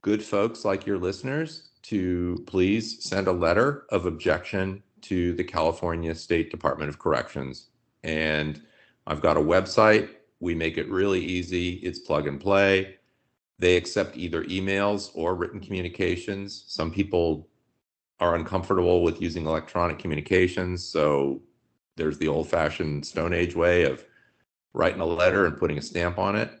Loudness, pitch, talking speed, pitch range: -26 LUFS, 90 Hz, 150 wpm, 80-100 Hz